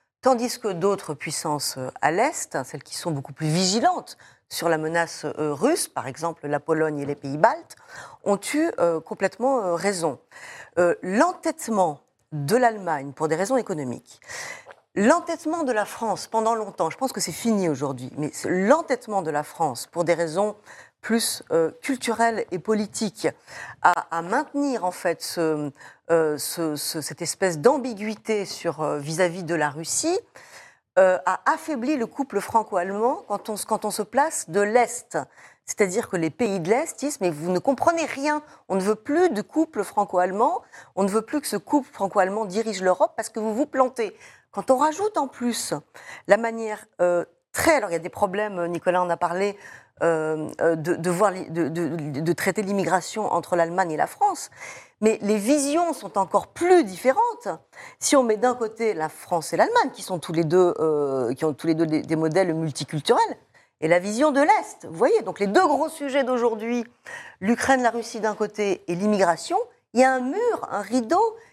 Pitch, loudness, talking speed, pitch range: 205 Hz, -24 LUFS, 185 wpm, 170-250 Hz